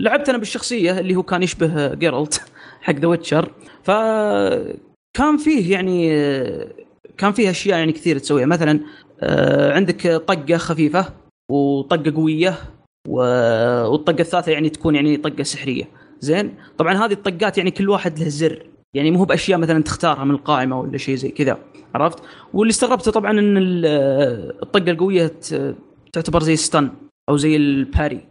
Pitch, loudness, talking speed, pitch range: 165 Hz, -18 LUFS, 140 wpm, 150-190 Hz